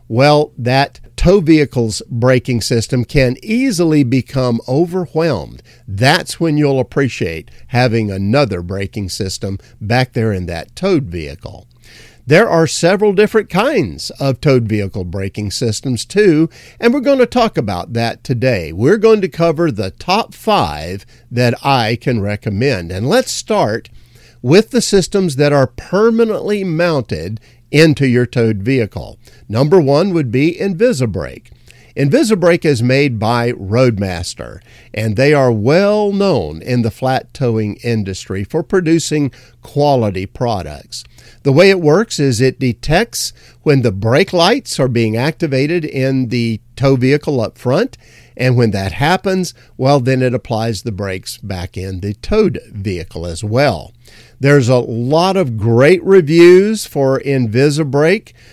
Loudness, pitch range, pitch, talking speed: -14 LUFS, 115-160 Hz, 130 Hz, 140 wpm